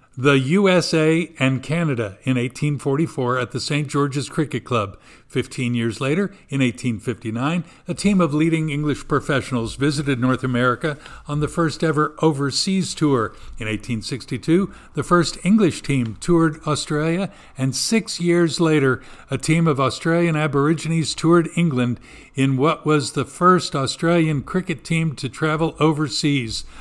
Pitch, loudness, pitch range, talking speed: 145 Hz, -20 LUFS, 130-165 Hz, 140 wpm